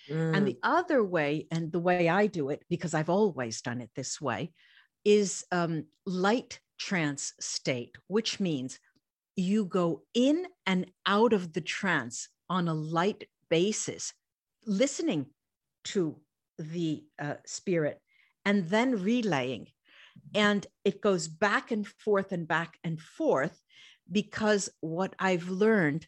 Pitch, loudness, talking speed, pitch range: 180 Hz, -30 LUFS, 135 wpm, 155-210 Hz